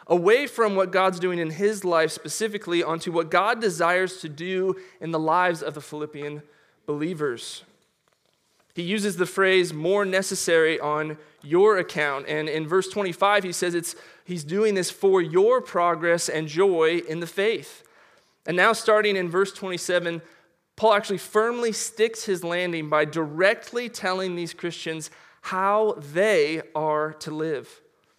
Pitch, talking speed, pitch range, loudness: 180 Hz, 150 wpm, 160-205 Hz, -24 LUFS